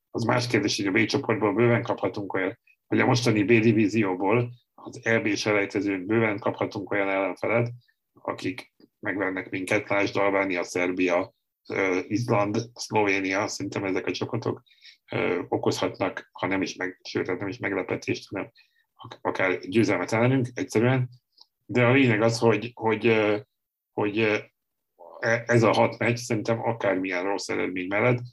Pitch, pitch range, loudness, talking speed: 115 Hz, 100-120 Hz, -25 LUFS, 135 wpm